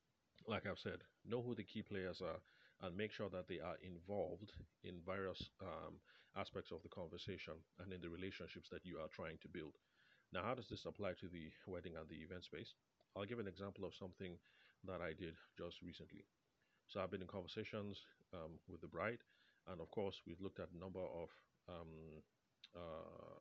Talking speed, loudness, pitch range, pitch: 195 wpm, -52 LUFS, 85-100 Hz, 95 Hz